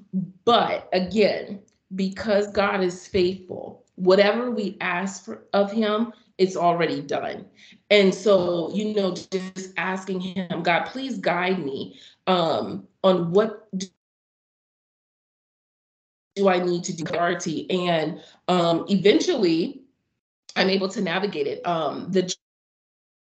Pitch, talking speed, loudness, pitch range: 190 Hz, 115 wpm, -23 LUFS, 180-205 Hz